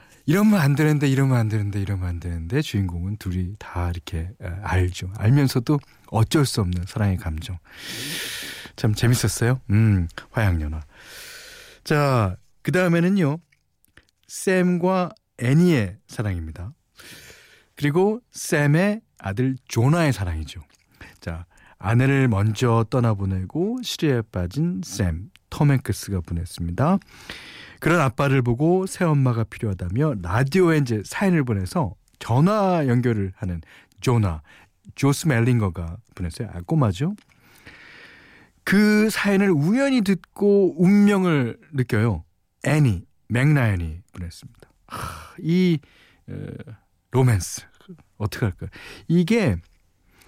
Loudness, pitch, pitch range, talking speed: -22 LUFS, 120 Hz, 95-160 Hz, 245 characters per minute